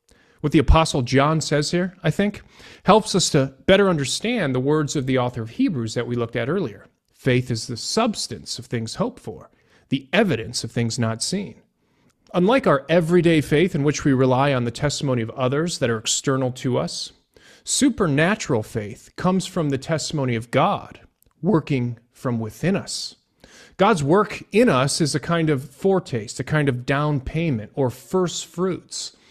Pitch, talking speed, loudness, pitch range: 145 Hz, 175 wpm, -21 LUFS, 125-175 Hz